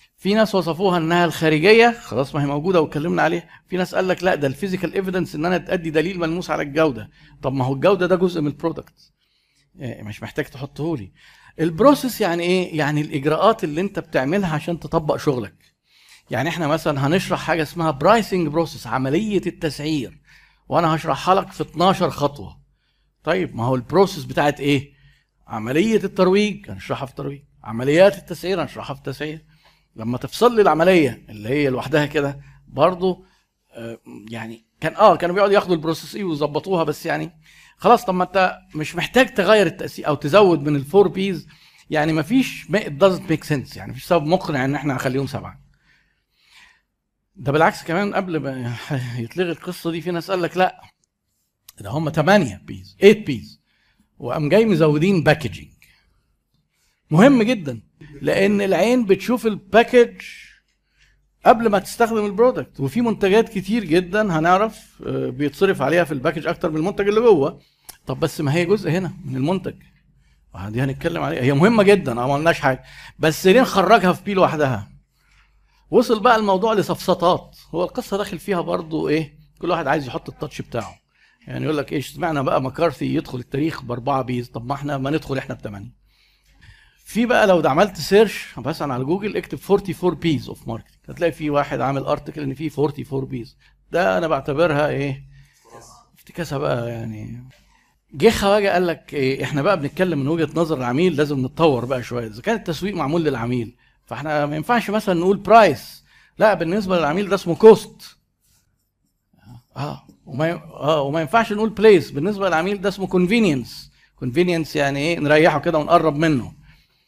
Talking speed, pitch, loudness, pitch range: 160 wpm, 160 Hz, -19 LUFS, 140-185 Hz